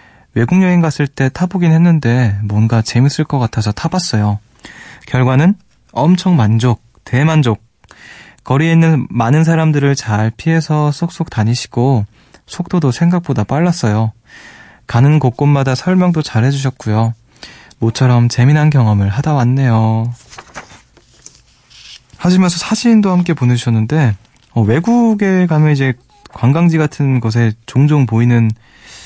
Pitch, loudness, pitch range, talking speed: 130 Hz, -13 LUFS, 115-160 Hz, 270 characters per minute